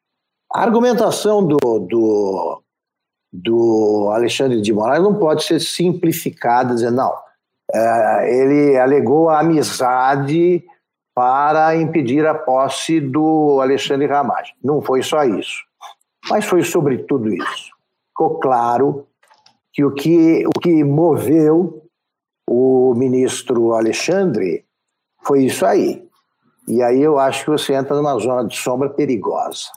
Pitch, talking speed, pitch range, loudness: 140 Hz, 125 wpm, 125-160 Hz, -16 LUFS